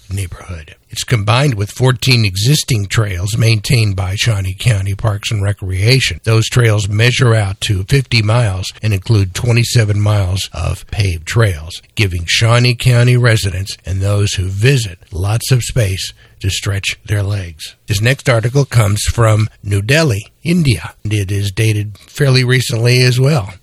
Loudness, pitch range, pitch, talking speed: -14 LUFS, 100-120 Hz, 110 Hz, 150 wpm